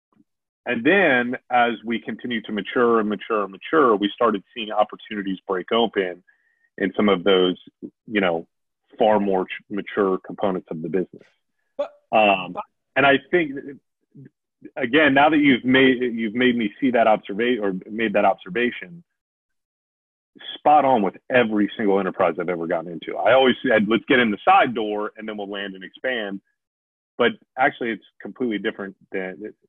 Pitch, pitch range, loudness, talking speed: 110 Hz, 100-125 Hz, -21 LUFS, 160 wpm